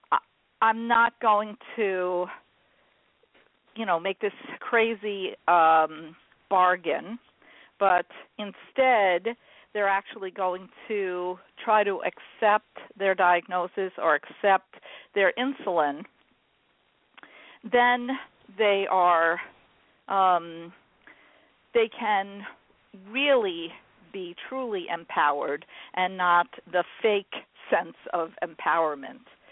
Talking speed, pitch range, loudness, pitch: 85 wpm, 180-235 Hz, -26 LUFS, 200 Hz